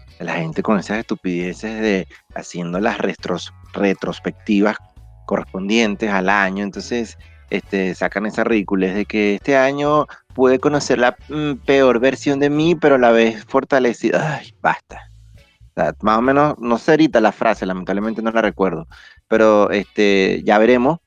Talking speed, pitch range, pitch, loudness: 155 wpm, 95-130 Hz, 110 Hz, -17 LUFS